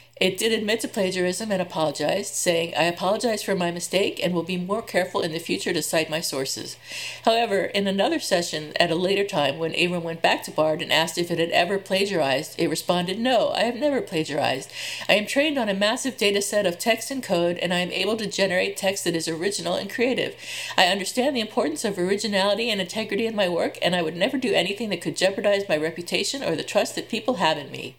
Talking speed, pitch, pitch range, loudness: 230 wpm, 190 Hz, 170-220 Hz, -23 LUFS